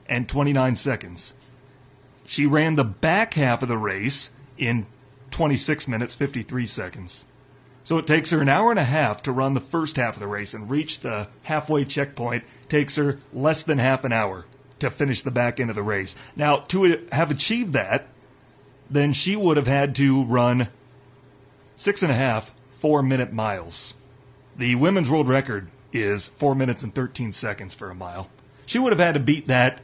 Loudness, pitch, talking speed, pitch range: -23 LUFS, 135 Hz, 190 wpm, 120-145 Hz